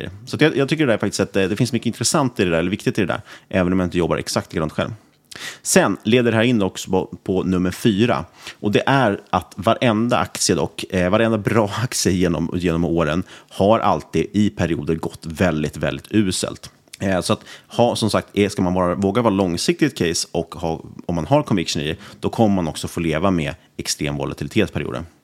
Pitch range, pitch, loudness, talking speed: 85-115 Hz, 95 Hz, -20 LUFS, 220 wpm